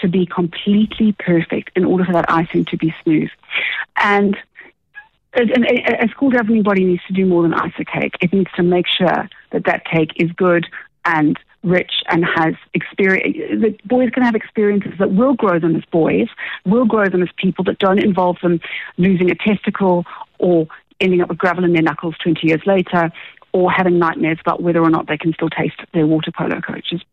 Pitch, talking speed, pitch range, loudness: 180 Hz, 200 wpm, 170-205 Hz, -16 LUFS